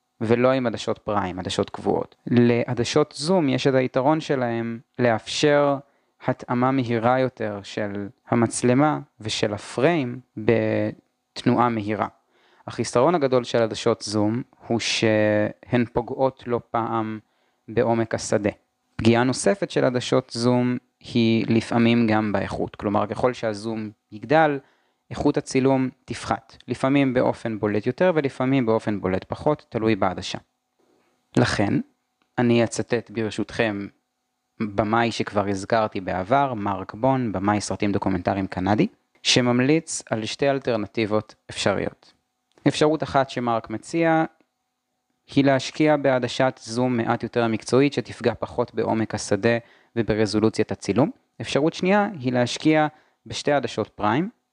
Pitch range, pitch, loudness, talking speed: 110-130 Hz, 115 Hz, -23 LUFS, 115 wpm